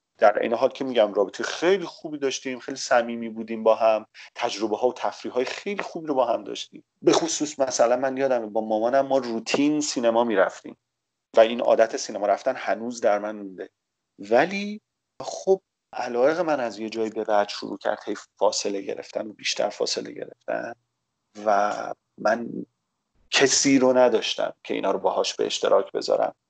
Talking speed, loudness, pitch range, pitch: 170 wpm, -24 LUFS, 110-140 Hz, 125 Hz